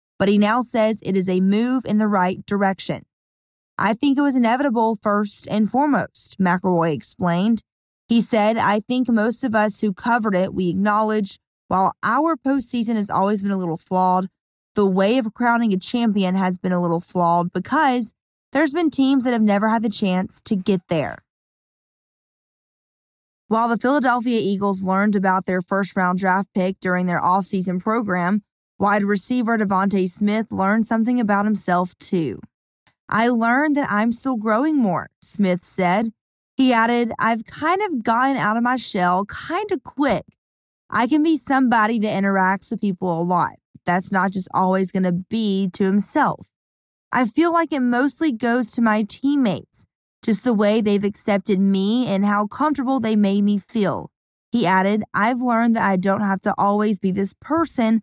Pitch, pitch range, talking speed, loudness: 210 Hz, 190-235 Hz, 175 wpm, -20 LUFS